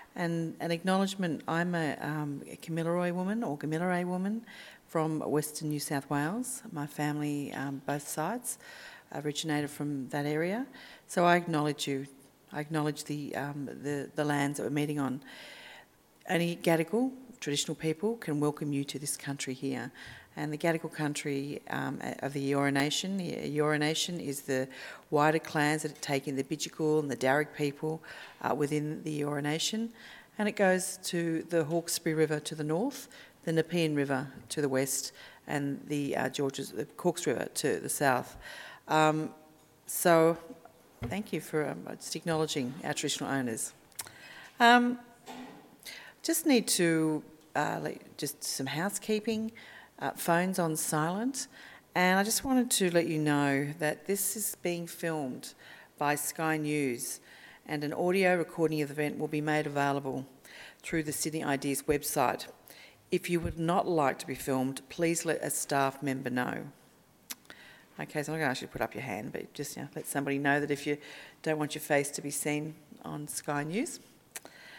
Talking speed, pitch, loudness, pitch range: 165 wpm, 155 Hz, -32 LUFS, 145-170 Hz